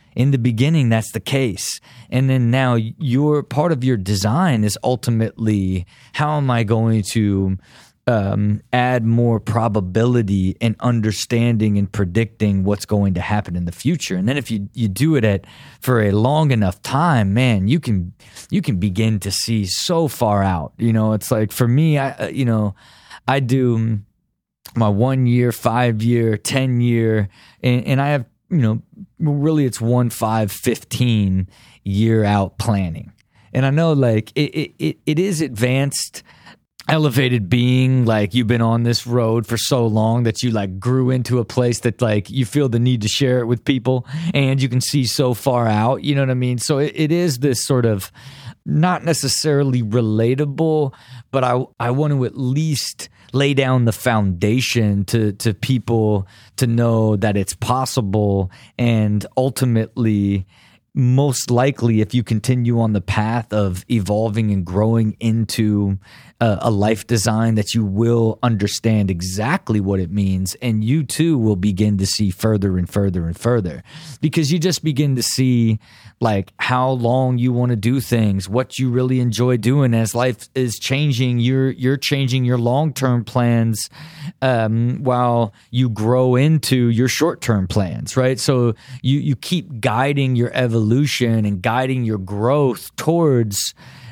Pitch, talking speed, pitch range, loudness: 120 Hz, 165 wpm, 110-130 Hz, -18 LUFS